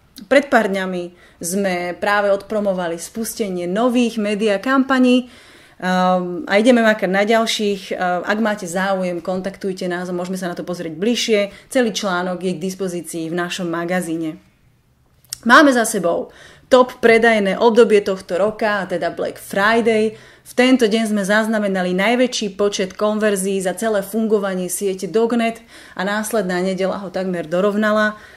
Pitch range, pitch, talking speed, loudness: 185-225 Hz, 200 Hz, 140 wpm, -18 LUFS